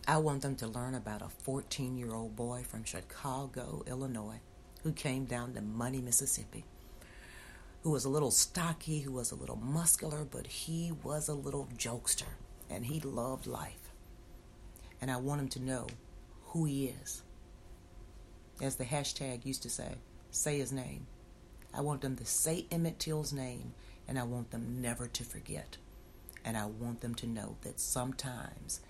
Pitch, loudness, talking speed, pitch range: 125 Hz, -37 LUFS, 165 wpm, 115-140 Hz